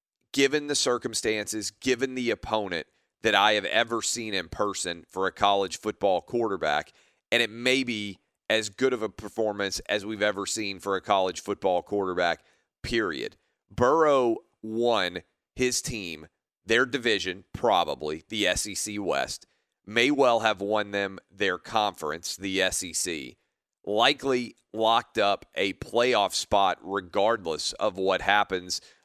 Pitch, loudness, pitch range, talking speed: 105 Hz, -26 LUFS, 95-115 Hz, 135 wpm